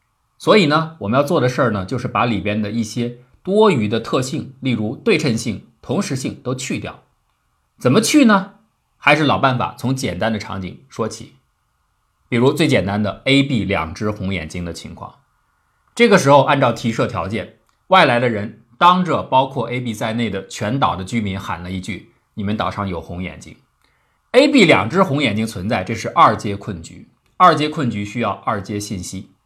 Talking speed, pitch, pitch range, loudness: 270 characters per minute, 115 Hz, 100-135 Hz, -17 LUFS